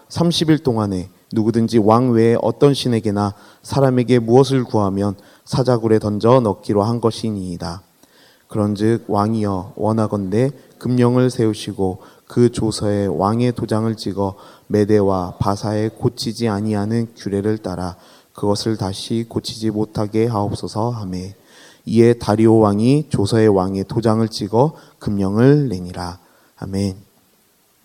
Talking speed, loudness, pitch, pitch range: 280 characters per minute, -18 LUFS, 110 Hz, 100-120 Hz